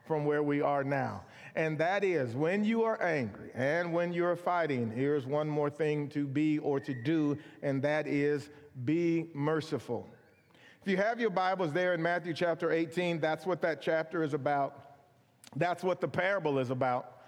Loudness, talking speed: -32 LUFS, 180 wpm